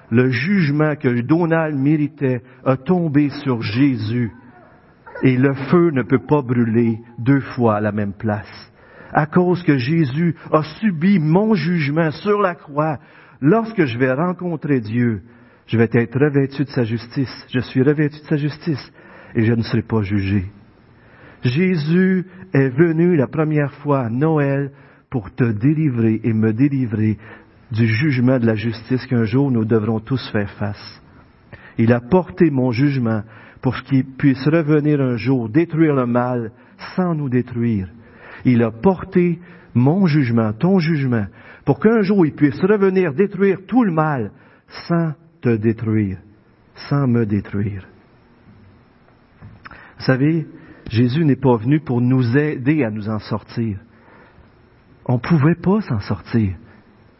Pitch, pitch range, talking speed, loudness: 130 Hz, 115-155 Hz, 150 wpm, -18 LUFS